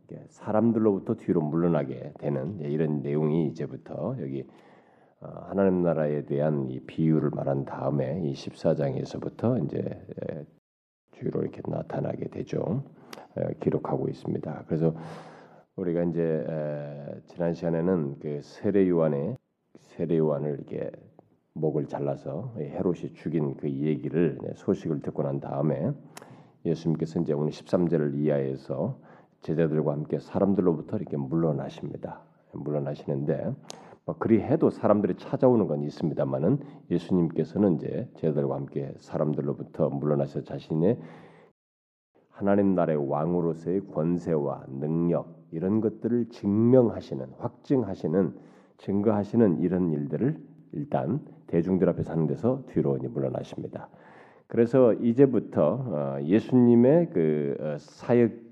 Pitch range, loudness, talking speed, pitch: 75-95 Hz, -27 LUFS, 295 characters per minute, 80 Hz